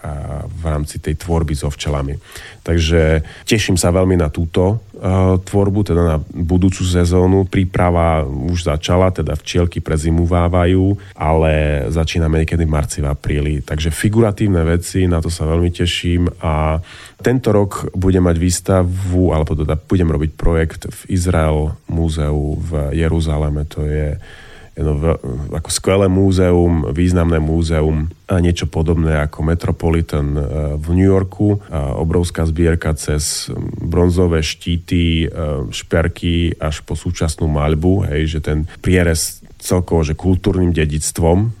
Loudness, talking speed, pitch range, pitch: -16 LUFS, 130 wpm, 80-90 Hz, 85 Hz